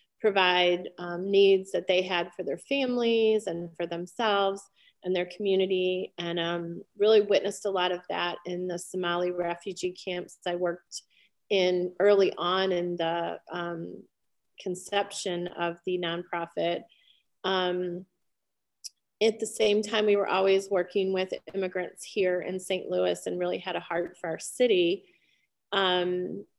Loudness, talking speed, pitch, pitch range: -28 LUFS, 145 wpm, 185 Hz, 175-195 Hz